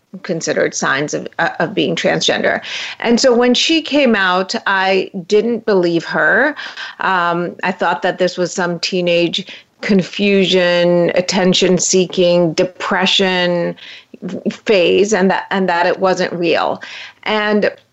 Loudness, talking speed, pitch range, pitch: -15 LUFS, 125 wpm, 175-200 Hz, 185 Hz